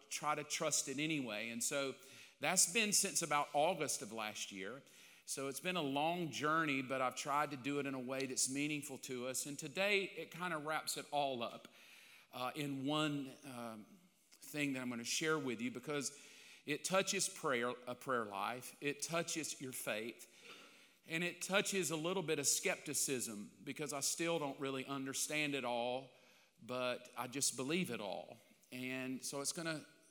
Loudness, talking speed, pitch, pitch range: -39 LUFS, 185 wpm, 145 Hz, 130-160 Hz